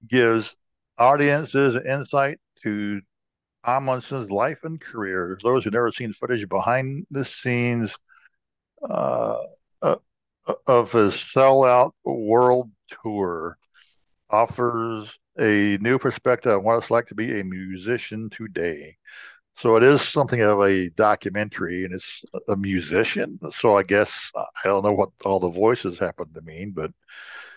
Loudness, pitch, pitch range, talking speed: -22 LUFS, 115 Hz, 100-130 Hz, 135 wpm